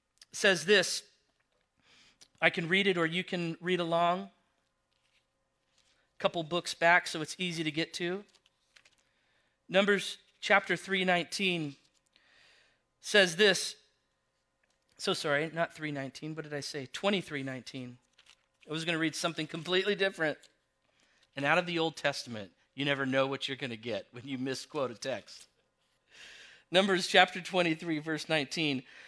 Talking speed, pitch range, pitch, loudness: 140 wpm, 140-185 Hz, 165 Hz, -30 LUFS